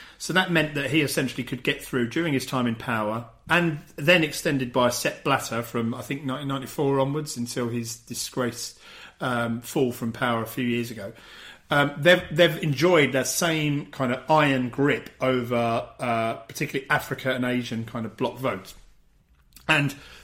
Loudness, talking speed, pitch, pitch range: -25 LUFS, 170 wpm, 130 Hz, 120-150 Hz